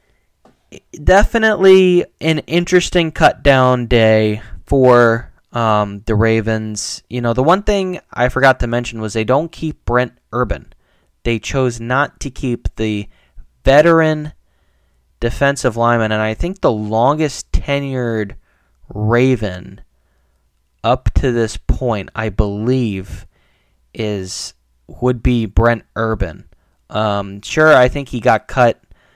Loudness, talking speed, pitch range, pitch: -15 LUFS, 120 wpm, 100-130 Hz, 115 Hz